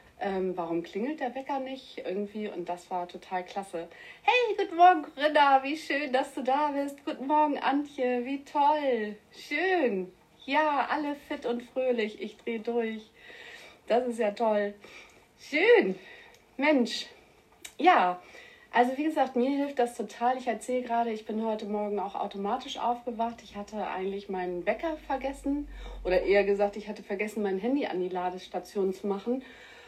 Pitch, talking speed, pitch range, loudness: 240 Hz, 160 wpm, 205-285 Hz, -29 LUFS